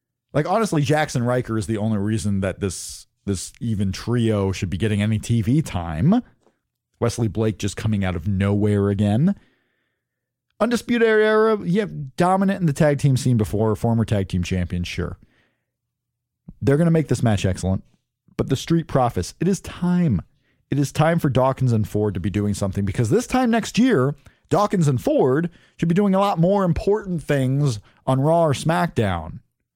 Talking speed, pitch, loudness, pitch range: 175 wpm, 125 Hz, -21 LUFS, 105-165 Hz